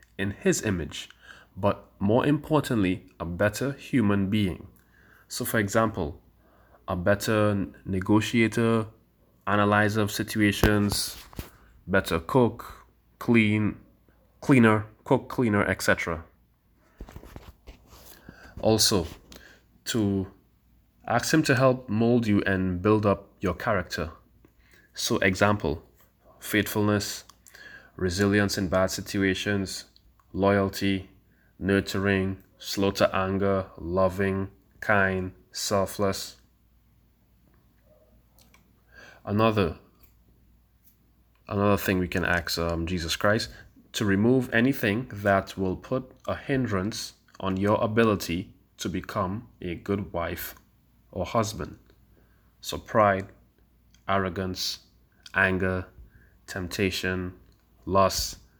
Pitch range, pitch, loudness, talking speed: 95-105 Hz, 100 Hz, -26 LUFS, 90 wpm